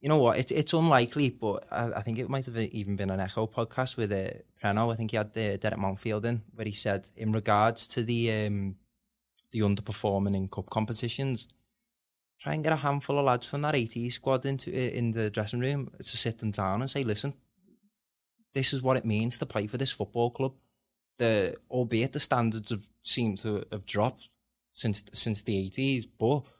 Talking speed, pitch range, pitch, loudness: 205 wpm, 105-130 Hz, 115 Hz, -29 LUFS